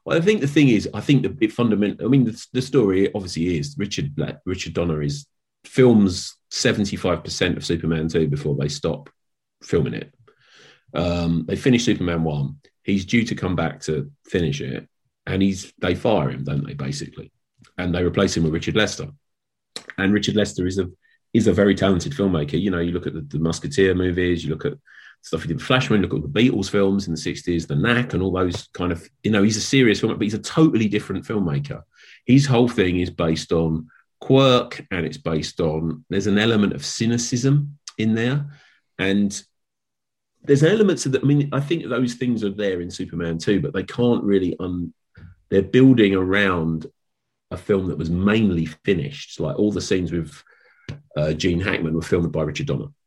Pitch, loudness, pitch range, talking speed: 95 Hz, -21 LUFS, 85-120 Hz, 200 wpm